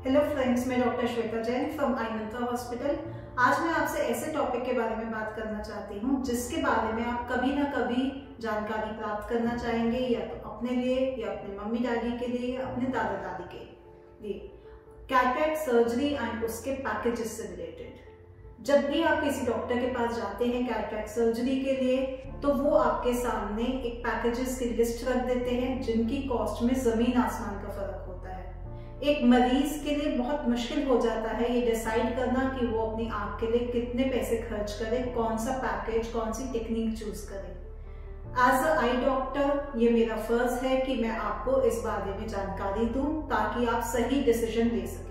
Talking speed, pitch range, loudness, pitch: 185 wpm, 225-255 Hz, -29 LUFS, 240 Hz